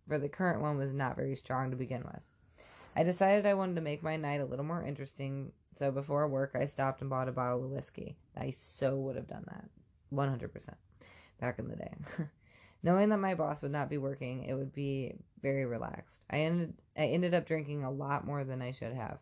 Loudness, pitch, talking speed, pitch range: -35 LUFS, 140 Hz, 220 wpm, 130-155 Hz